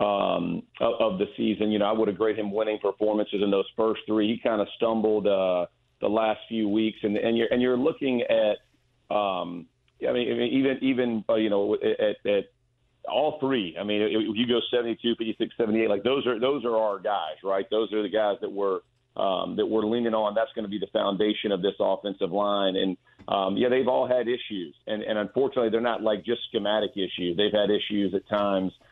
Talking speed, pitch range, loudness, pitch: 220 wpm, 105-120 Hz, -26 LUFS, 110 Hz